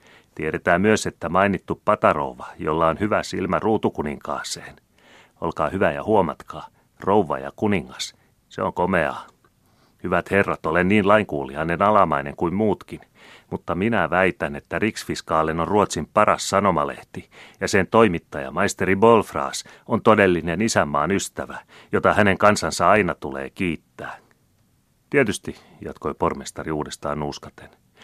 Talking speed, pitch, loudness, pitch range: 120 wpm, 95 Hz, -21 LUFS, 85-105 Hz